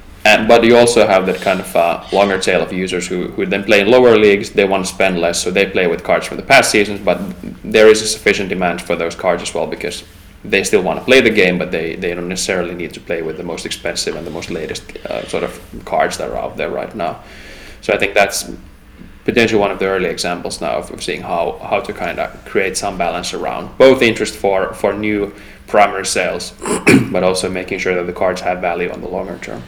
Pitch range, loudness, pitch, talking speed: 90-110 Hz, -15 LUFS, 100 Hz, 245 wpm